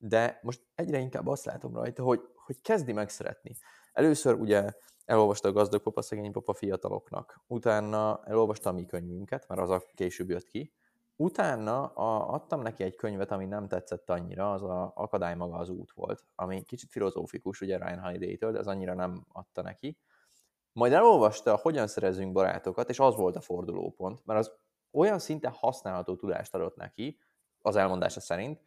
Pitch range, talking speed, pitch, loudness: 90-115 Hz, 165 wpm, 105 Hz, -31 LUFS